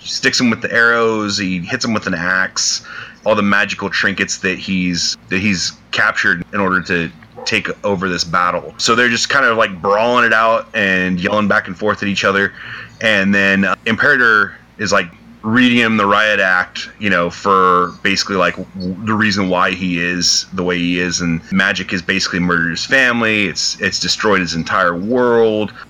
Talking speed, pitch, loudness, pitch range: 190 wpm, 95 Hz, -14 LUFS, 90-105 Hz